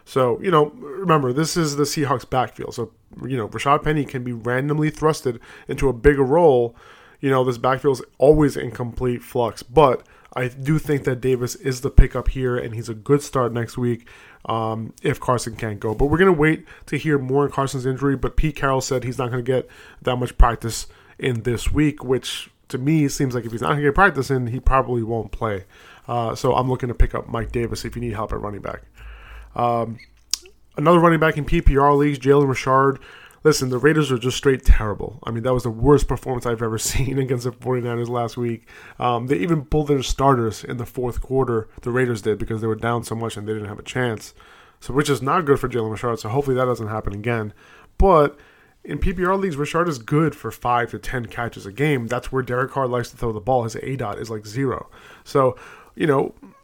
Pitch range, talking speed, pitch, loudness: 115-140 Hz, 225 wpm, 125 Hz, -21 LUFS